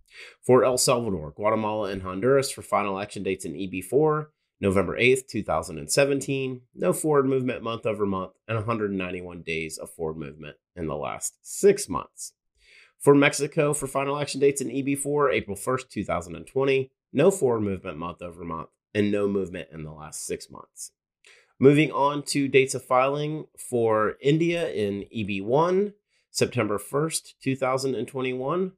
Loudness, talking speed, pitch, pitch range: -25 LUFS, 145 wpm, 125 Hz, 100-140 Hz